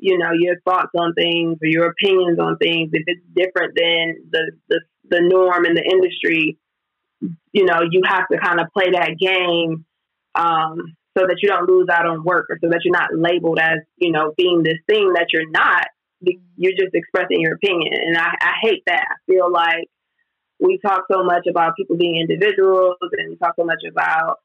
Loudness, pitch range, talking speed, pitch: -17 LUFS, 165-185 Hz, 205 wpm, 175 Hz